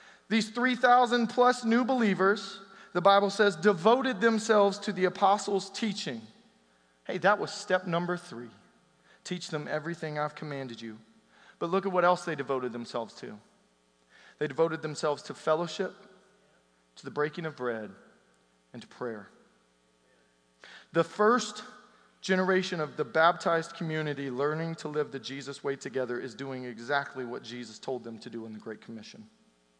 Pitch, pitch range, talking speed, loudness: 155 Hz, 120-195 Hz, 150 wpm, -29 LUFS